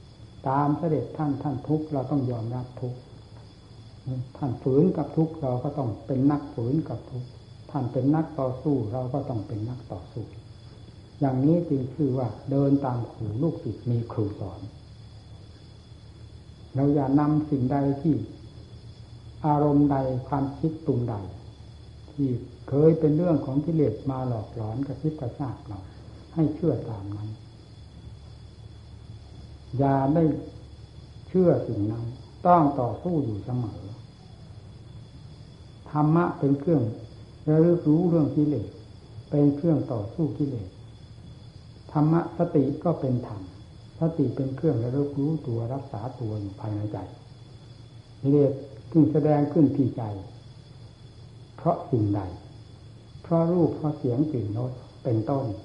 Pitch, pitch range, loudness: 125 Hz, 110-145 Hz, -26 LUFS